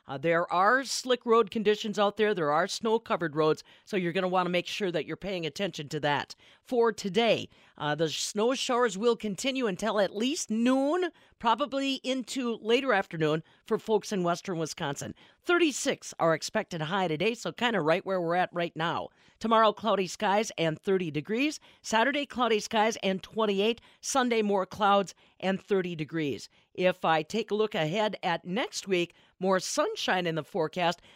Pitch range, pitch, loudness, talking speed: 170-230 Hz, 200 Hz, -29 LUFS, 180 wpm